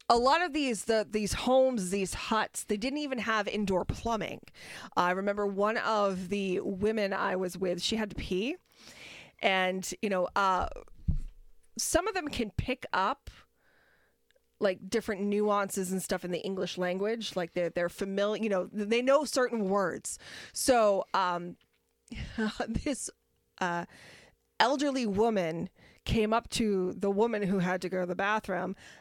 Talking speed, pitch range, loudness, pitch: 155 wpm, 185-225 Hz, -31 LUFS, 205 Hz